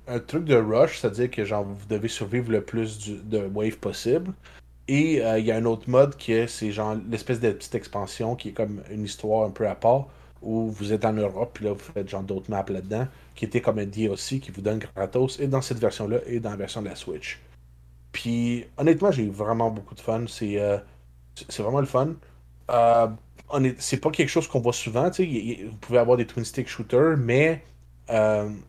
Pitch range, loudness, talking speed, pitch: 105-125 Hz, -25 LUFS, 220 wpm, 110 Hz